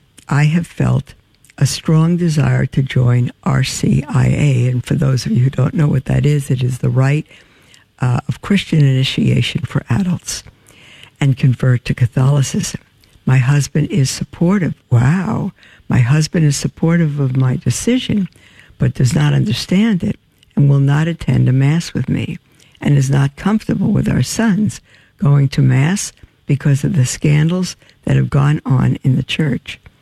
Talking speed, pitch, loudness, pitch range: 160 wpm, 140 Hz, -15 LUFS, 130-155 Hz